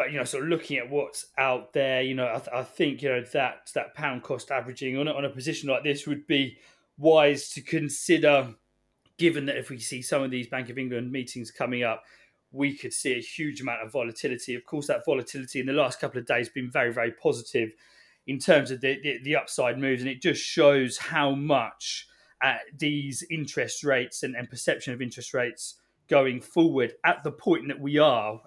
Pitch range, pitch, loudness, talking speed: 125-145 Hz, 135 Hz, -27 LUFS, 215 wpm